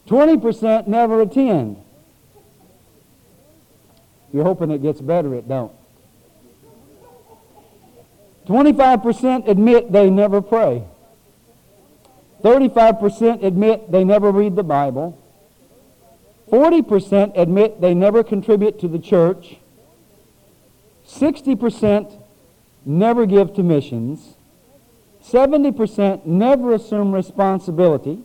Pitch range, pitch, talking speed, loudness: 170-230 Hz, 205 Hz, 85 wpm, -16 LUFS